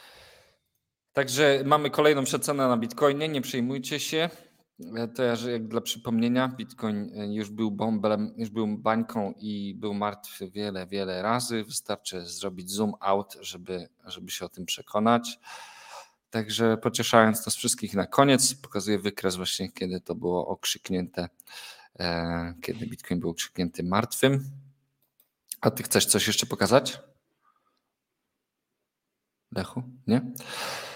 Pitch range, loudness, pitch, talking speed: 100-130 Hz, -27 LUFS, 110 Hz, 125 wpm